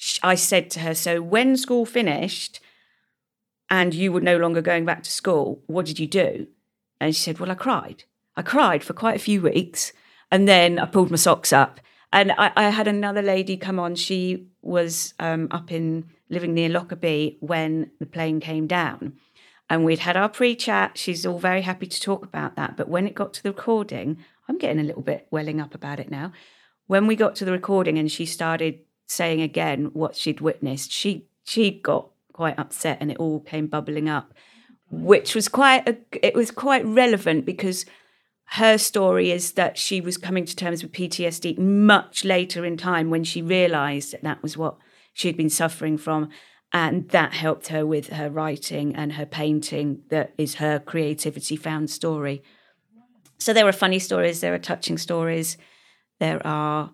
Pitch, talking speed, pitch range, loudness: 170 Hz, 190 wpm, 155-190 Hz, -22 LUFS